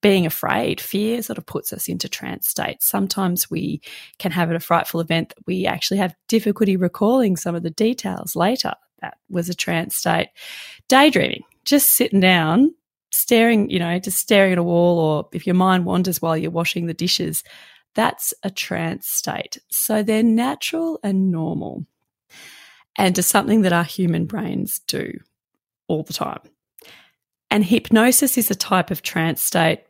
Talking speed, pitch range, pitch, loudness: 170 wpm, 175-225 Hz, 190 Hz, -19 LUFS